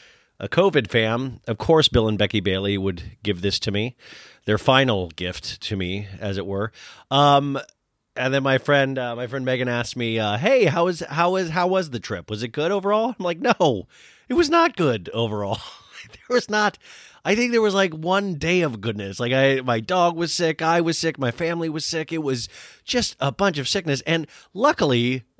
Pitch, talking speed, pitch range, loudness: 135 Hz, 210 wpm, 110-170 Hz, -22 LUFS